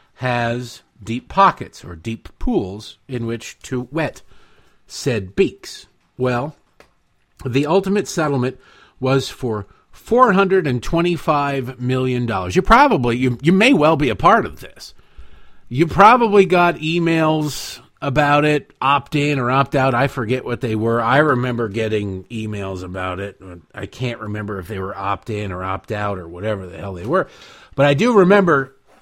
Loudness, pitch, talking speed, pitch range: -18 LUFS, 125 Hz, 155 wpm, 105-150 Hz